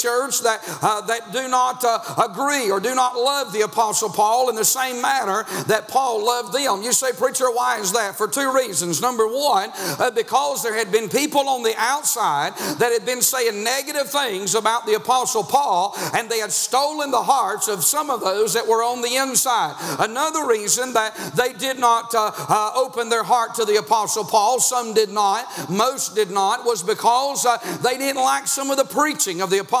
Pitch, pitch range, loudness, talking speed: 240 Hz, 220-260 Hz, -20 LUFS, 205 wpm